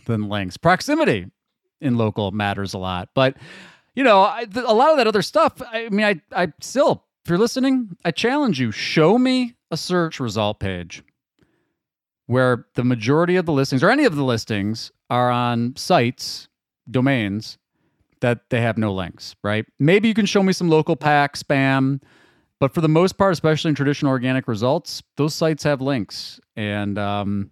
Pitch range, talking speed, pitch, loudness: 115-180 Hz, 180 wpm, 140 Hz, -20 LUFS